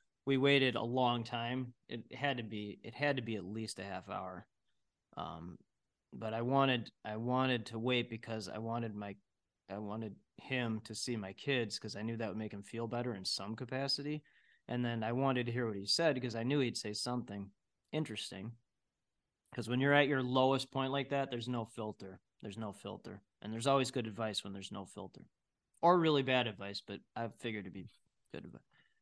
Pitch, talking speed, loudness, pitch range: 115 Hz, 205 wpm, -37 LUFS, 105-130 Hz